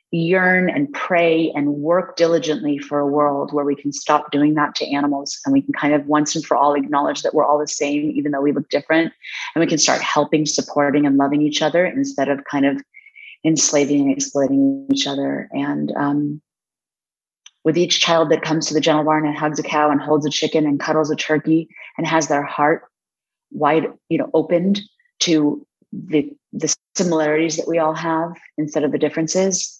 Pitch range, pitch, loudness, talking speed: 145-165 Hz, 155 Hz, -18 LUFS, 200 wpm